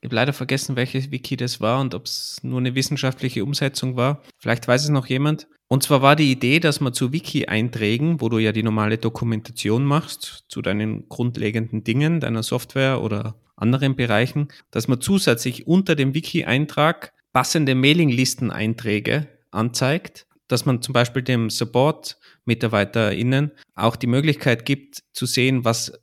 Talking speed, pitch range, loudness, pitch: 155 wpm, 115-140 Hz, -21 LUFS, 130 Hz